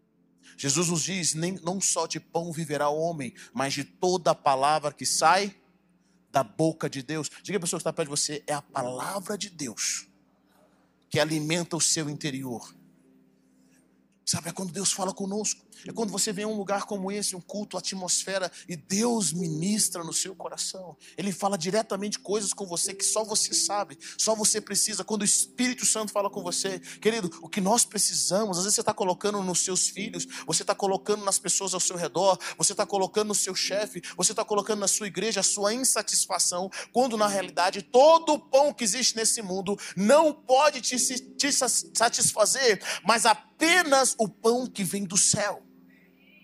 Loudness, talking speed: -25 LUFS, 185 wpm